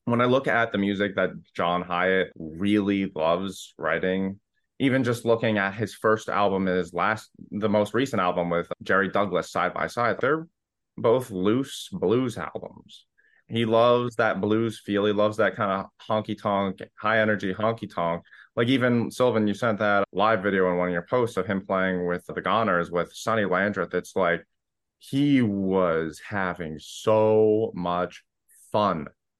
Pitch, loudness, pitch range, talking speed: 105 Hz, -25 LUFS, 95-115 Hz, 165 wpm